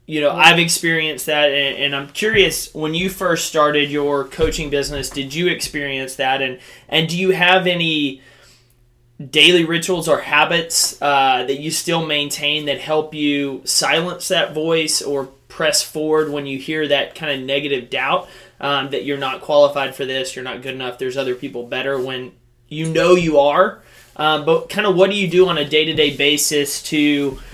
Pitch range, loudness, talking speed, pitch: 135-165 Hz, -17 LUFS, 190 wpm, 145 Hz